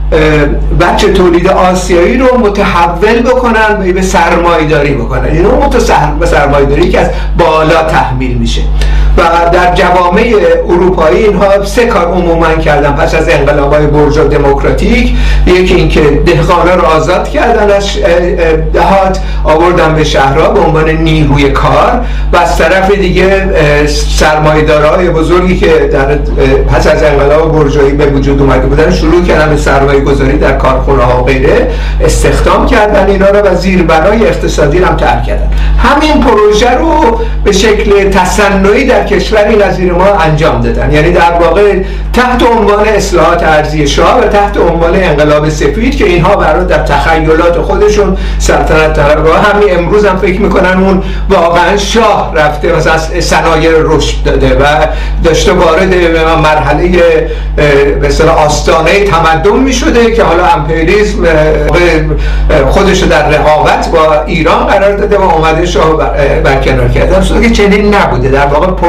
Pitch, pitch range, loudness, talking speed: 170 Hz, 150-200 Hz, -7 LUFS, 140 wpm